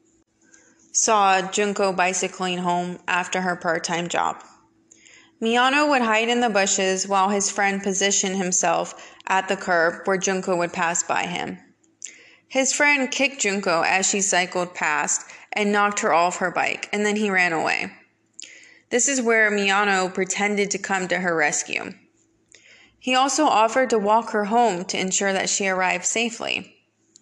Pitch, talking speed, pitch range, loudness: 195 Hz, 155 wpm, 180-225 Hz, -21 LUFS